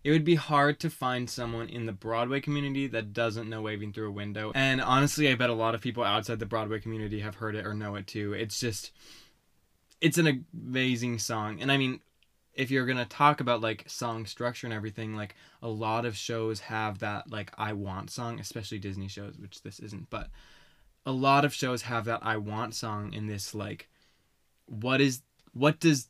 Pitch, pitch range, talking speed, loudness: 115 Hz, 105-130 Hz, 210 wpm, -30 LUFS